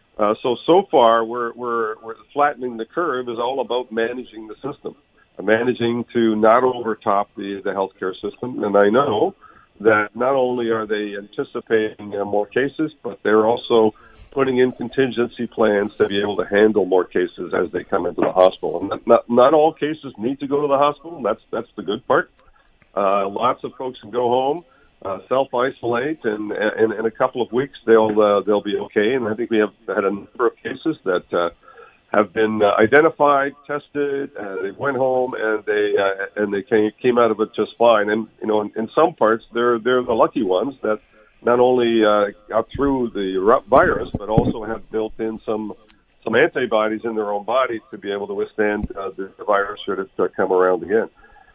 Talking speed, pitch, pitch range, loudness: 205 wpm, 110 Hz, 105-125 Hz, -20 LUFS